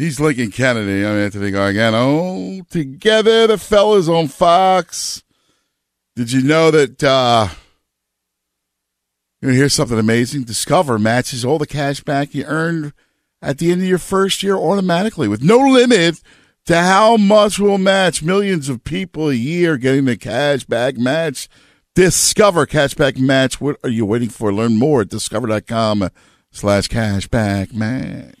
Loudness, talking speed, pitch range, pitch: -15 LUFS, 150 wpm, 115-170 Hz, 140 Hz